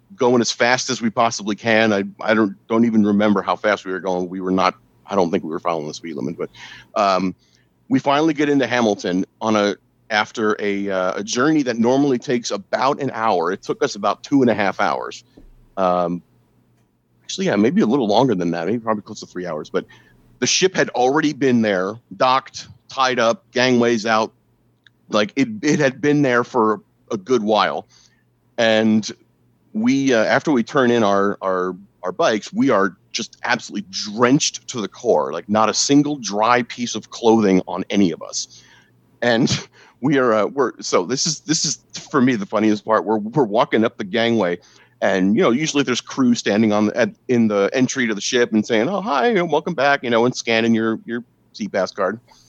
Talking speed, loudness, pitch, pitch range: 205 wpm, -19 LUFS, 110 Hz, 100-125 Hz